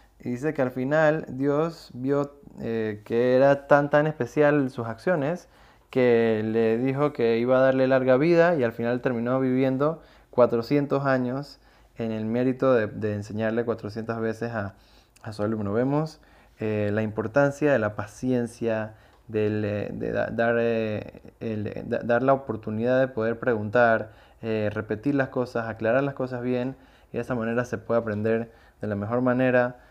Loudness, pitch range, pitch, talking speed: -25 LUFS, 110-135 Hz, 120 Hz, 165 wpm